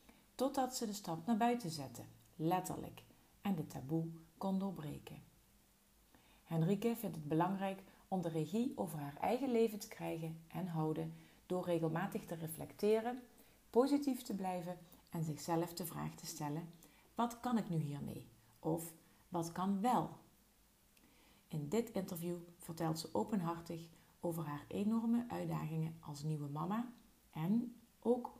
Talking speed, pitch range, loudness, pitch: 135 wpm, 160-220 Hz, -41 LUFS, 175 Hz